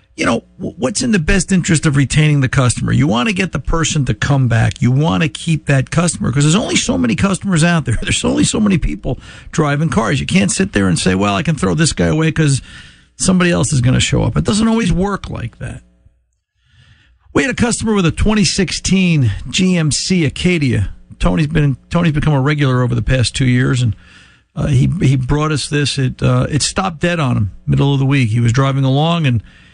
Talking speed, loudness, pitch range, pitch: 225 wpm, -14 LUFS, 130-175 Hz, 145 Hz